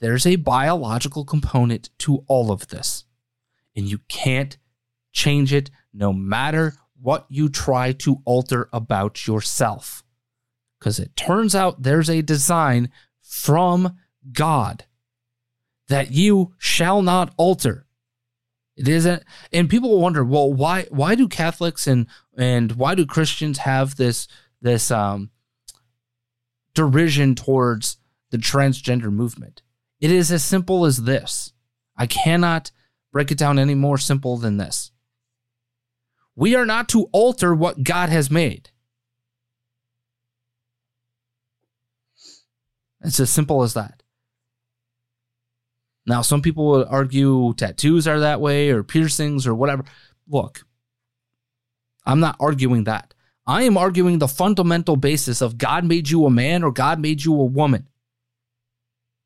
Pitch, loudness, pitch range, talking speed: 130 Hz, -19 LUFS, 120-155 Hz, 130 wpm